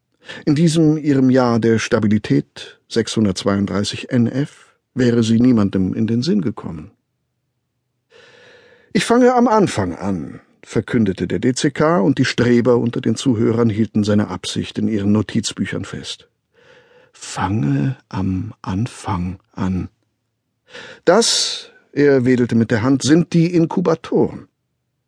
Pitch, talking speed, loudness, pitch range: 120 Hz, 115 wpm, -17 LUFS, 105-140 Hz